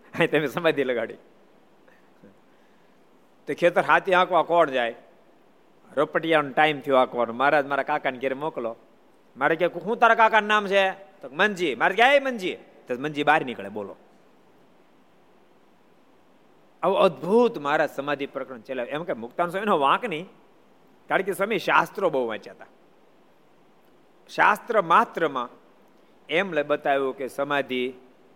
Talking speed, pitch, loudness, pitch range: 130 wpm, 150 Hz, -23 LUFS, 135-185 Hz